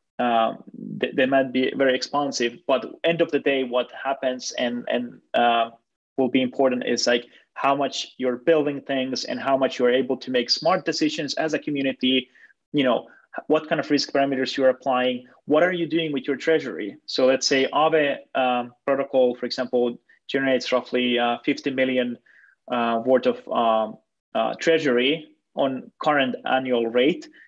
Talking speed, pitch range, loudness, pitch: 170 wpm, 125-140 Hz, -23 LUFS, 130 Hz